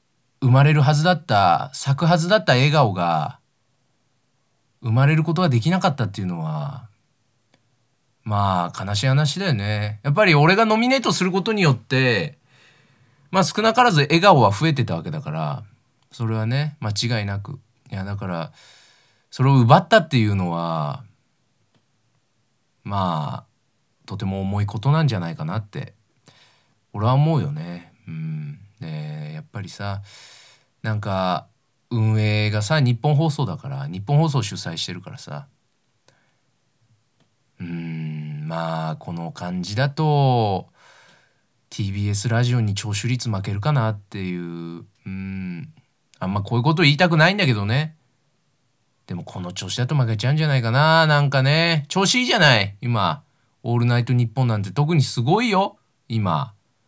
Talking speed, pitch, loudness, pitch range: 290 characters per minute, 125 Hz, -20 LUFS, 105-150 Hz